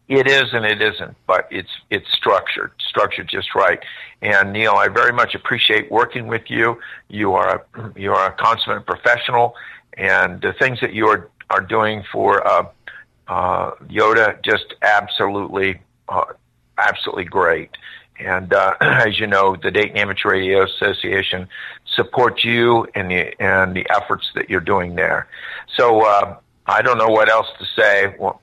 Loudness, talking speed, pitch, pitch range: -17 LUFS, 165 wpm, 105 Hz, 95-120 Hz